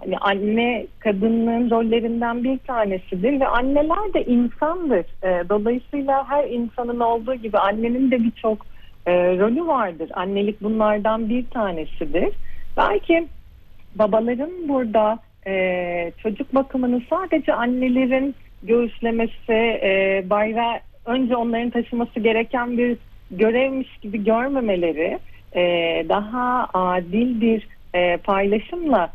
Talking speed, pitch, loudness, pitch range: 105 wpm, 230 Hz, -21 LUFS, 205-250 Hz